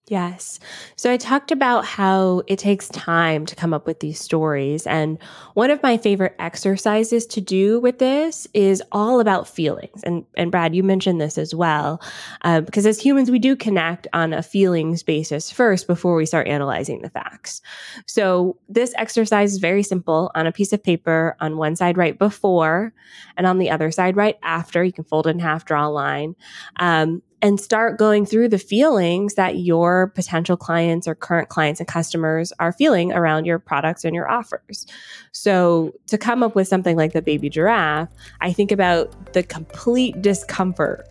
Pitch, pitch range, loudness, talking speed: 180 Hz, 160-205 Hz, -19 LUFS, 185 wpm